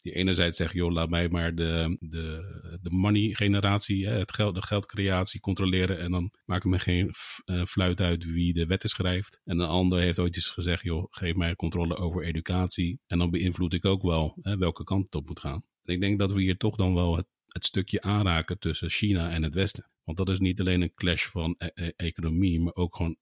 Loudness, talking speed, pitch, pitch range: -28 LUFS, 215 wpm, 90 Hz, 85-95 Hz